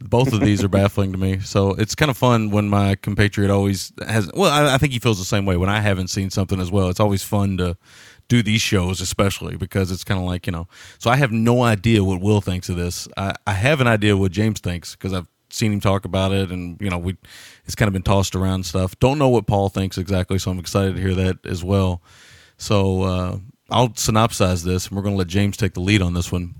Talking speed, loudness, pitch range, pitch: 260 wpm, -20 LUFS, 95-110 Hz, 100 Hz